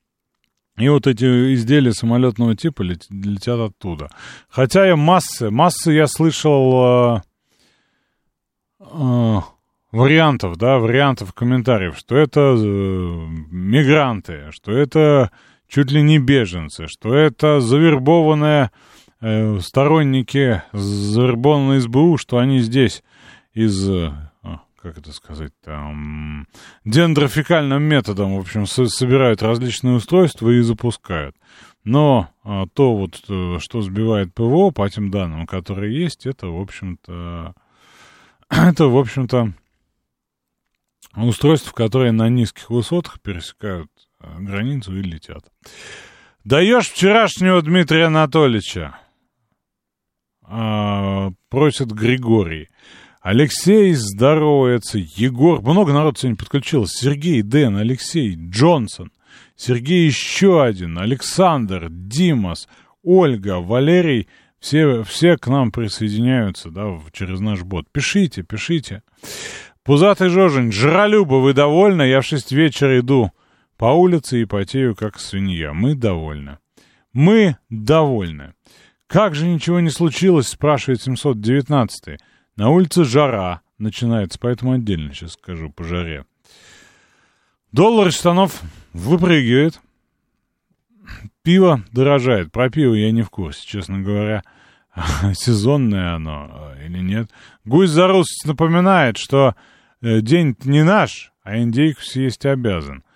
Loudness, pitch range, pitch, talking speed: -16 LUFS, 100-150 Hz, 120 Hz, 105 wpm